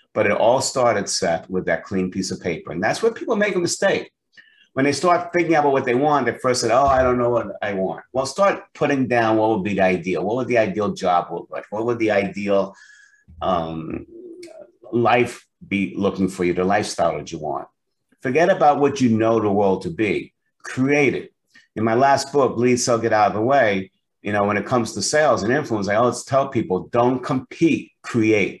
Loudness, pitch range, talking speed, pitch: -20 LUFS, 100-145 Hz, 220 wpm, 120 Hz